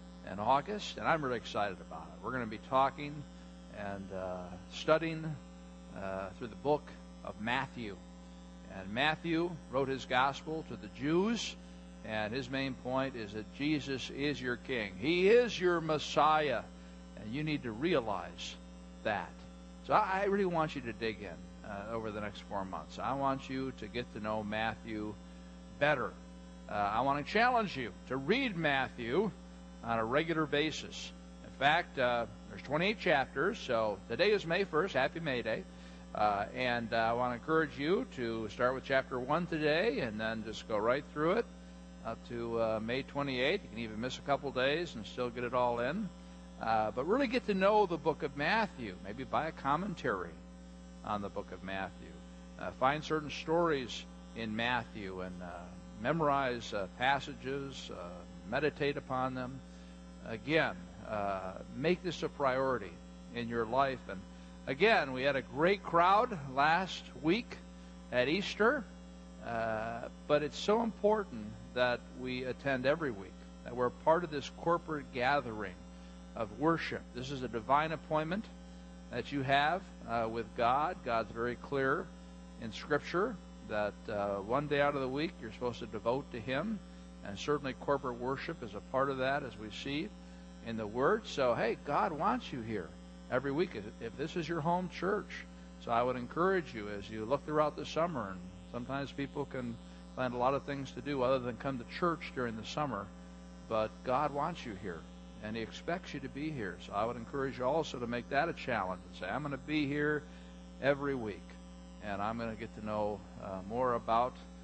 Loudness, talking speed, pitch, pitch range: -35 LUFS, 180 wpm, 120 Hz, 90-145 Hz